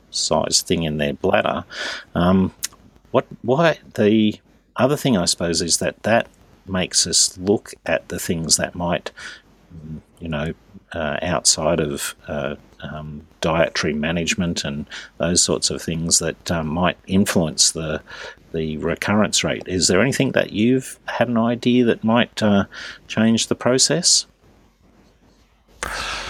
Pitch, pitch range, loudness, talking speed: 95 Hz, 80-110 Hz, -19 LUFS, 135 wpm